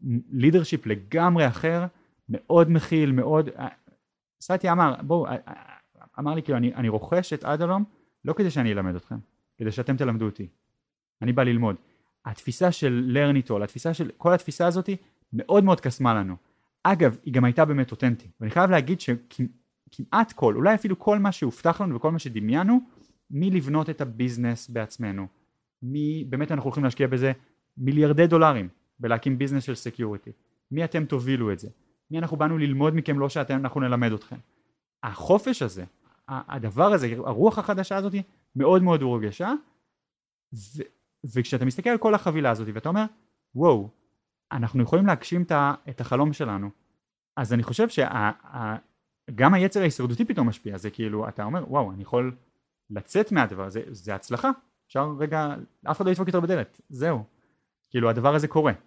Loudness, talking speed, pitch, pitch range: -24 LUFS, 155 wpm, 140 Hz, 120-170 Hz